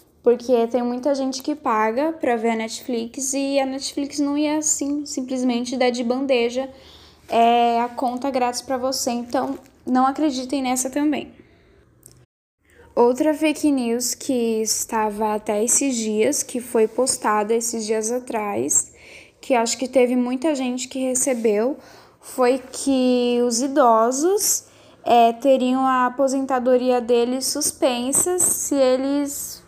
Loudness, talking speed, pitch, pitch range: -20 LUFS, 130 wpm, 255 Hz, 240-275 Hz